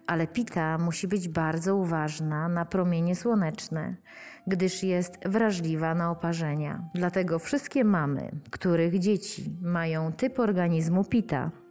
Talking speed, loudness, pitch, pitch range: 120 wpm, -28 LUFS, 175 Hz, 165-195 Hz